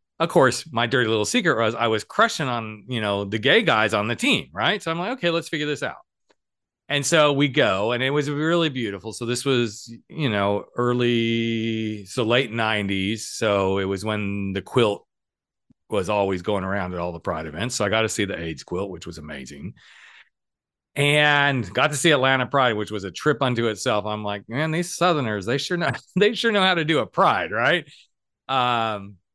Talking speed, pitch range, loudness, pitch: 210 wpm, 105-145 Hz, -22 LUFS, 120 Hz